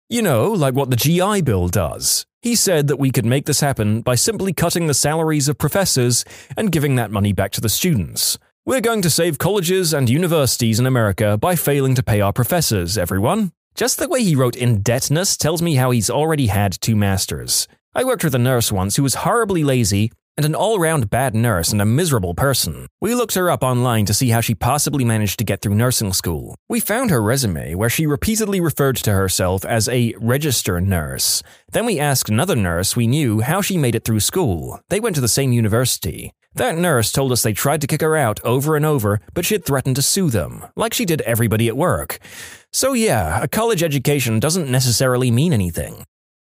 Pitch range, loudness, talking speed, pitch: 110-160 Hz, -18 LUFS, 215 wpm, 130 Hz